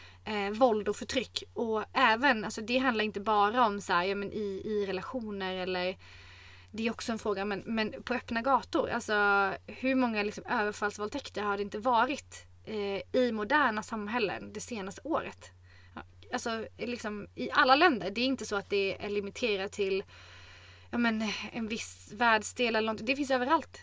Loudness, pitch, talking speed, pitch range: -31 LUFS, 210 Hz, 175 wpm, 195-235 Hz